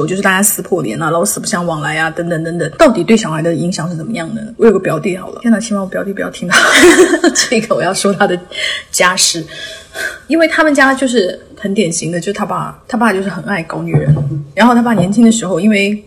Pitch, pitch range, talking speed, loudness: 195 Hz, 170-225 Hz, 350 characters per minute, -12 LUFS